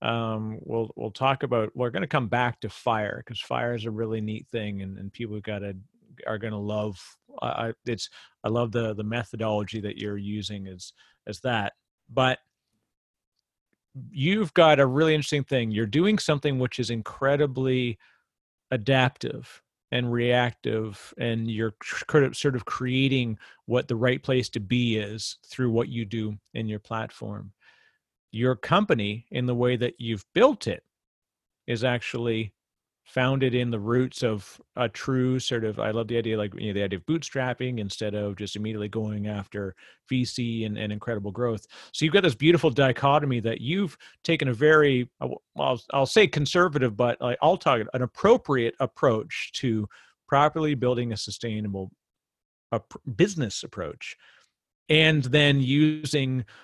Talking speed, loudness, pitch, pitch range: 160 wpm, -26 LUFS, 120 Hz, 110-130 Hz